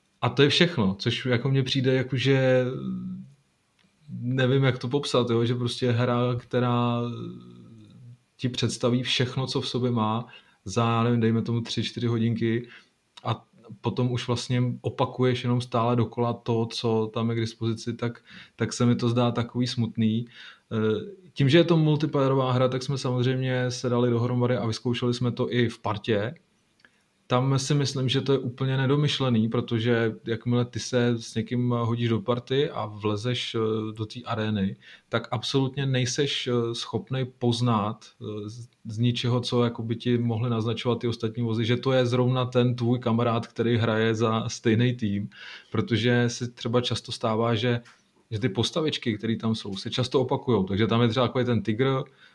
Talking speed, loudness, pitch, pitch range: 165 wpm, -26 LUFS, 120 Hz, 115-125 Hz